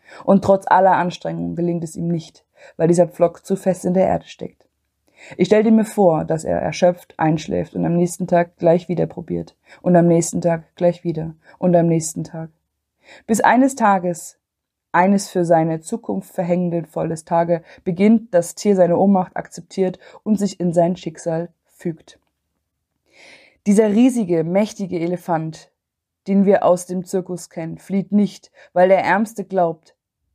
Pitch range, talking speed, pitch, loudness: 165-190 Hz, 160 wpm, 175 Hz, -18 LUFS